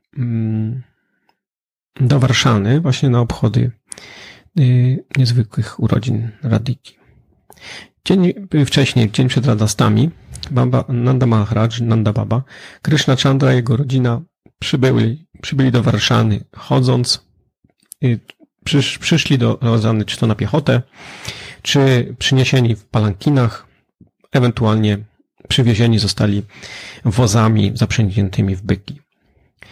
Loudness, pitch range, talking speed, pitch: -16 LUFS, 110-130 Hz, 100 wpm, 120 Hz